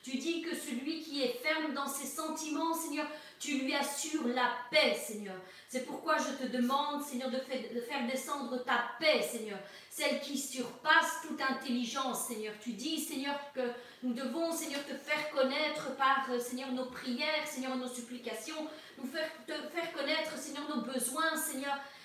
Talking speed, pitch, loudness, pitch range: 165 wpm, 275 Hz, -35 LUFS, 255-305 Hz